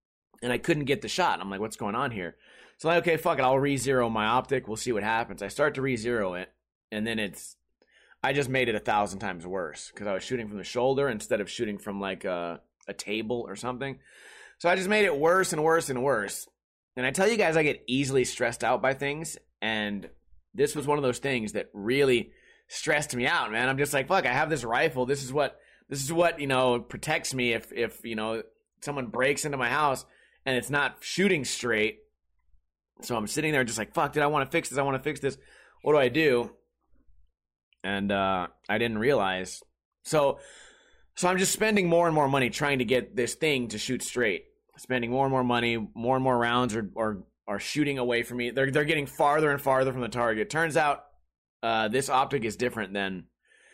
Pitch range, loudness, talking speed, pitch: 110-145 Hz, -27 LUFS, 225 wpm, 130 Hz